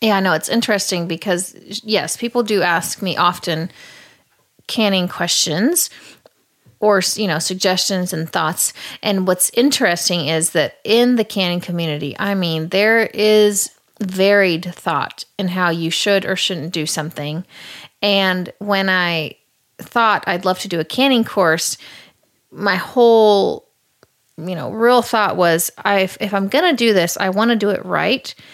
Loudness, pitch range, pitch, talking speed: -17 LUFS, 175-210 Hz, 190 Hz, 155 wpm